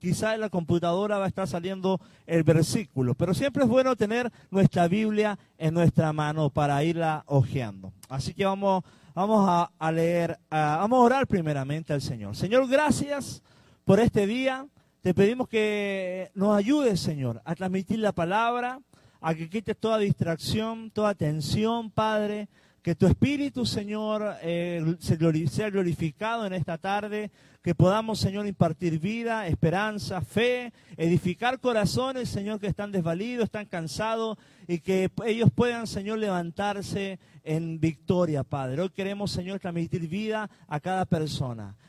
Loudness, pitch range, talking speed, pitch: -27 LUFS, 165-215 Hz, 145 wpm, 190 Hz